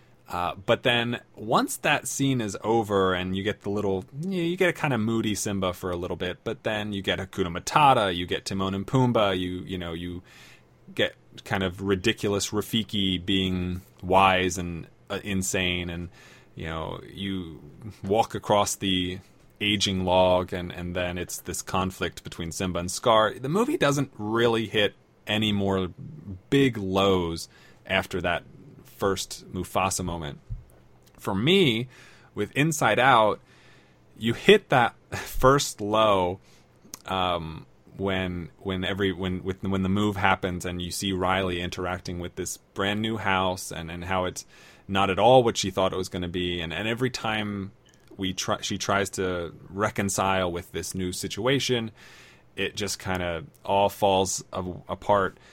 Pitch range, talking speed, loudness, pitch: 90-110 Hz, 165 wpm, -26 LUFS, 95 Hz